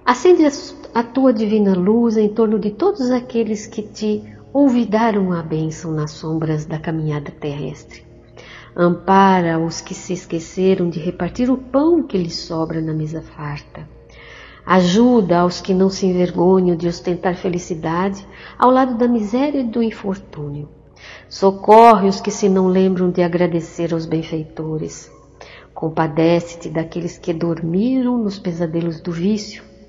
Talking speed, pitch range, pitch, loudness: 140 wpm, 165-215 Hz, 180 Hz, -17 LUFS